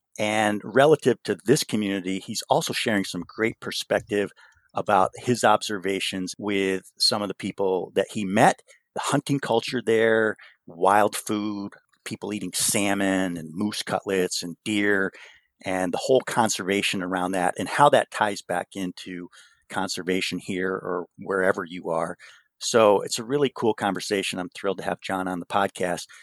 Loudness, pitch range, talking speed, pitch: -24 LUFS, 95-110 Hz, 155 wpm, 100 Hz